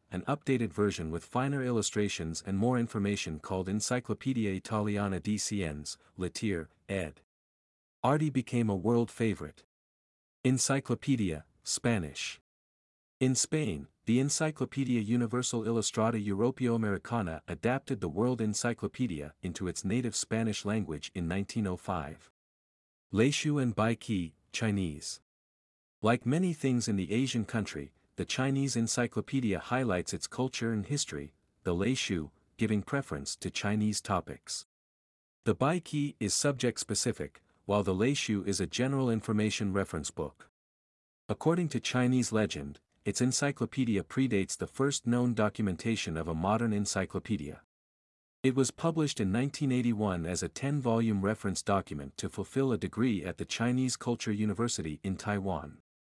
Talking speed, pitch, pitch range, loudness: 125 wpm, 105 Hz, 95-125 Hz, -32 LUFS